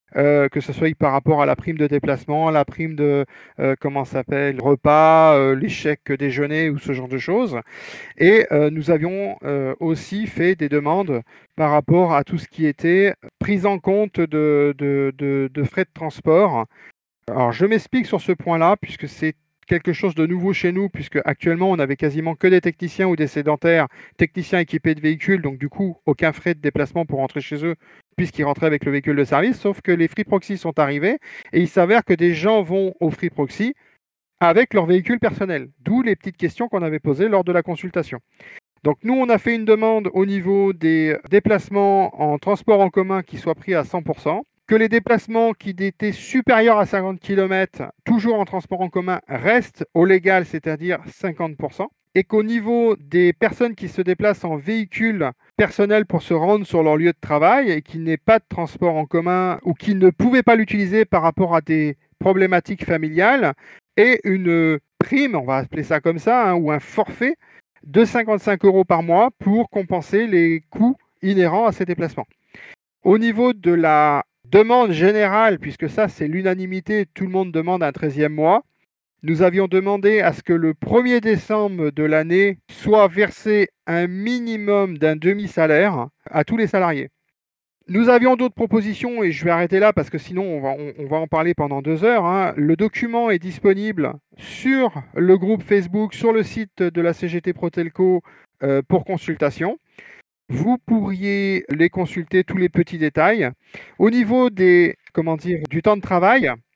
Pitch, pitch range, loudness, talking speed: 180 Hz, 155-205 Hz, -19 LUFS, 185 wpm